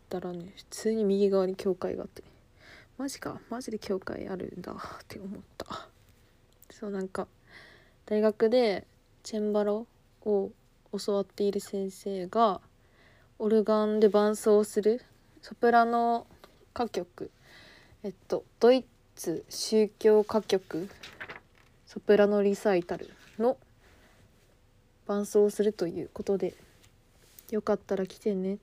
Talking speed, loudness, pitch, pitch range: 230 characters per minute, -29 LUFS, 205 Hz, 190-215 Hz